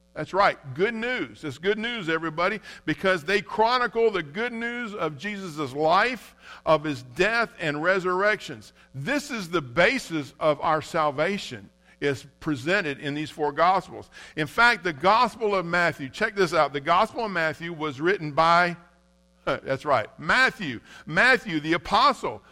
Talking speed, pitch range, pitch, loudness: 150 wpm, 150-210 Hz, 170 Hz, -24 LUFS